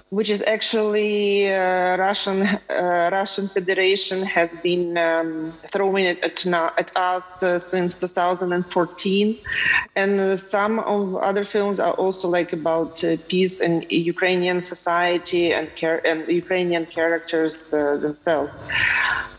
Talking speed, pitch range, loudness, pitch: 125 wpm, 170-195 Hz, -21 LUFS, 180 Hz